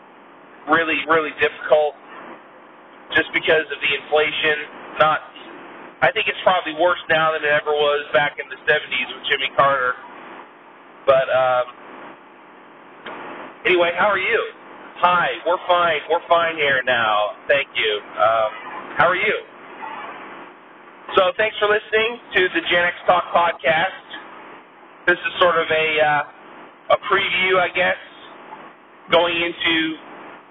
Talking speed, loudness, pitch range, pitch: 130 wpm, -19 LUFS, 150-185 Hz, 165 Hz